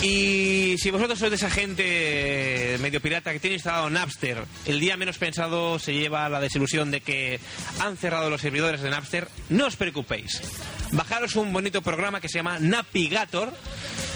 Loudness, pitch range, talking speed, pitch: -25 LUFS, 145-190 Hz, 170 wpm, 170 Hz